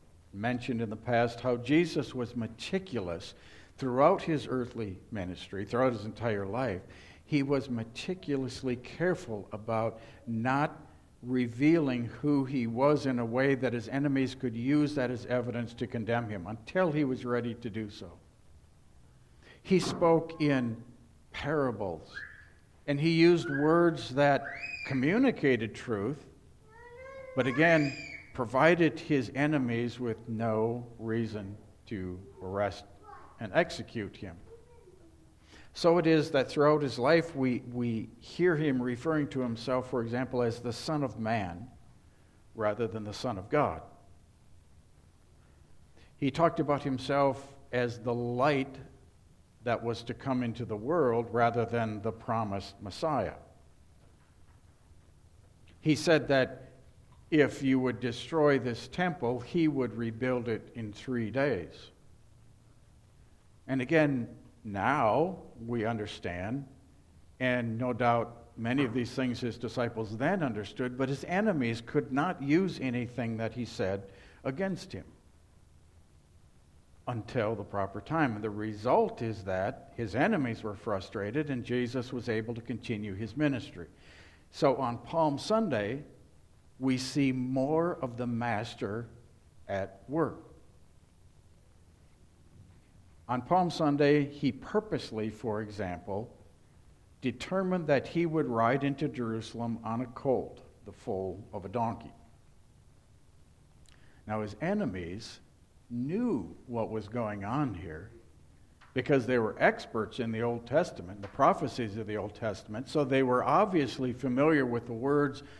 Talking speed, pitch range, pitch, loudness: 130 wpm, 105-135 Hz, 120 Hz, -31 LUFS